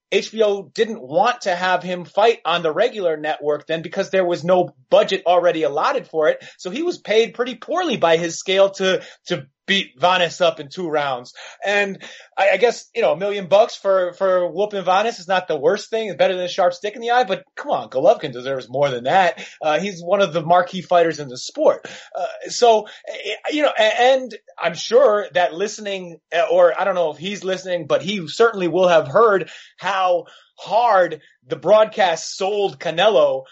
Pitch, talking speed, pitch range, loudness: 185 Hz, 200 wpm, 170-210 Hz, -19 LUFS